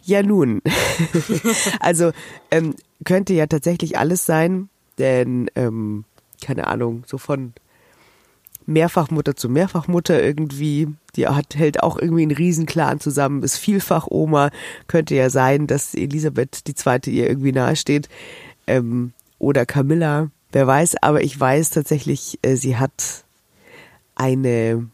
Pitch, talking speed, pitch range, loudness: 150 Hz, 130 wpm, 130-165 Hz, -19 LUFS